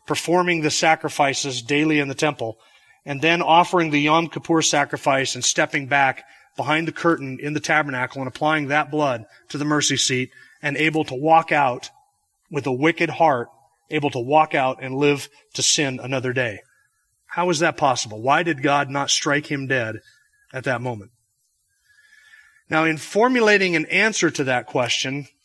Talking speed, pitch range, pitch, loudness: 170 wpm, 135-165 Hz, 150 Hz, -20 LUFS